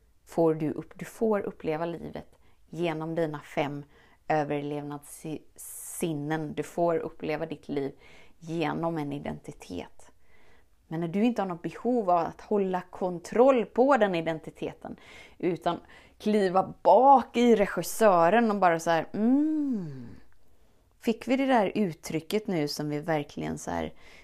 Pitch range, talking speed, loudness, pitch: 150-210 Hz, 130 wpm, -27 LUFS, 165 Hz